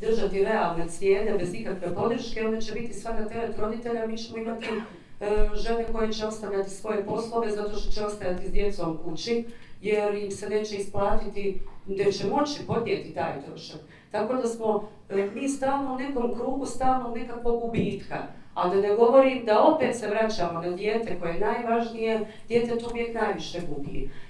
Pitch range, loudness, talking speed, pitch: 200-230 Hz, -28 LUFS, 175 wpm, 215 Hz